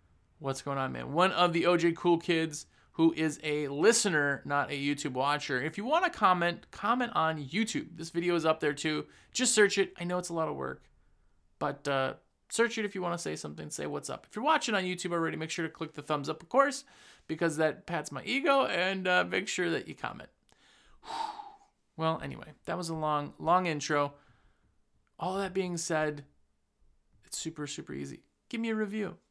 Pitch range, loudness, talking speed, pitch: 145-195 Hz, -31 LUFS, 210 wpm, 165 Hz